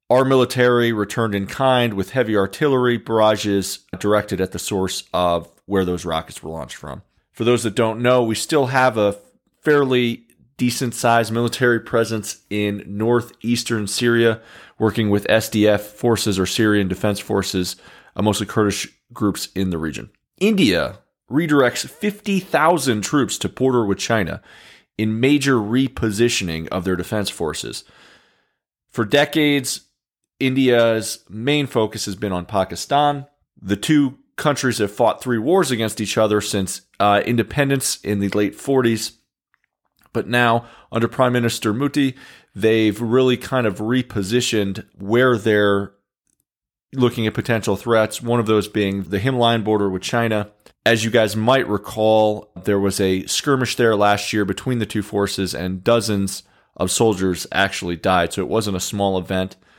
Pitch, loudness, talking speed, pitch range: 110 Hz, -19 LUFS, 145 wpm, 100-120 Hz